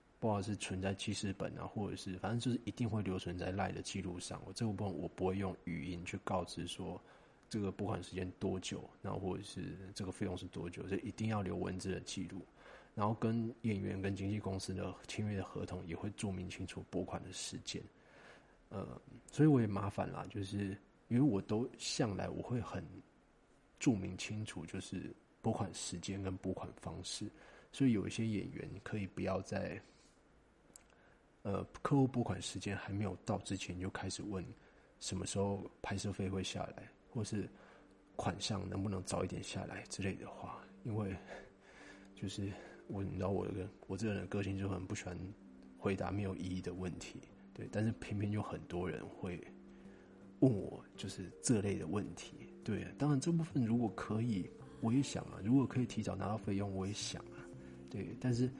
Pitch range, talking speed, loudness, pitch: 95-110 Hz, 275 characters per minute, -40 LUFS, 100 Hz